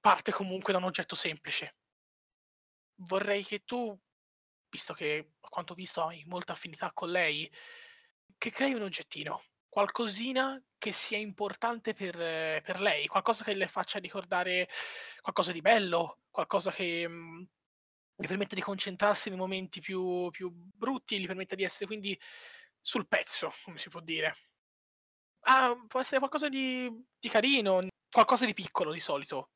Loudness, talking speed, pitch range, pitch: -31 LUFS, 150 wpm, 180-235 Hz, 195 Hz